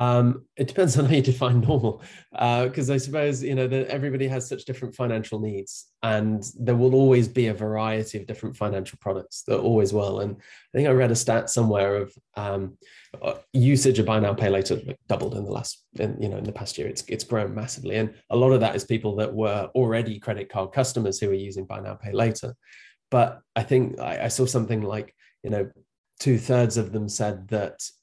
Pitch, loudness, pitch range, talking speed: 115 Hz, -24 LUFS, 105-130 Hz, 220 wpm